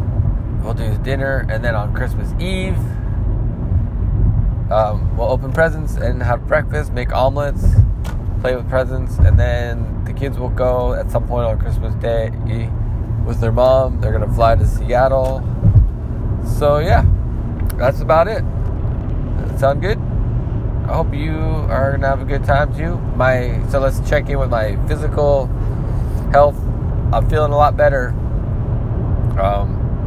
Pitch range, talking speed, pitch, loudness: 105-125 Hz, 150 wpm, 115 Hz, -18 LUFS